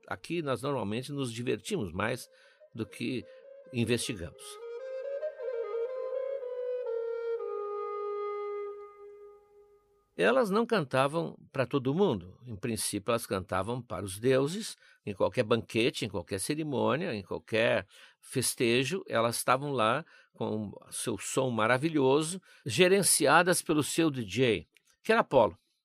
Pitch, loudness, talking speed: 165 Hz, -30 LUFS, 105 wpm